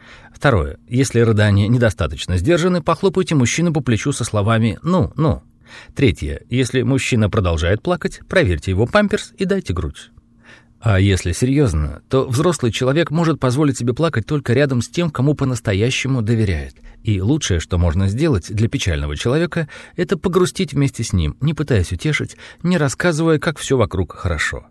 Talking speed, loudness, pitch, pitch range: 155 wpm, -18 LUFS, 125 Hz, 105-160 Hz